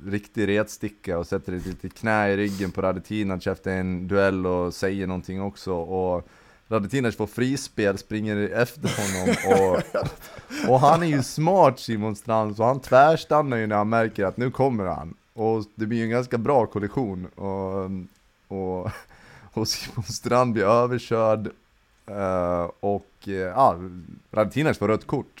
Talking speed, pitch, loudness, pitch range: 155 wpm, 105 Hz, -24 LUFS, 95-115 Hz